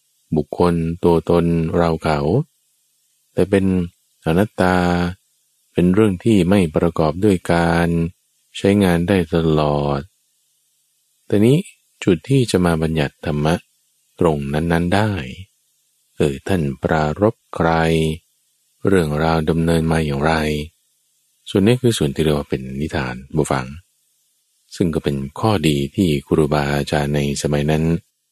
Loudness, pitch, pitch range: -18 LUFS, 85 Hz, 75-90 Hz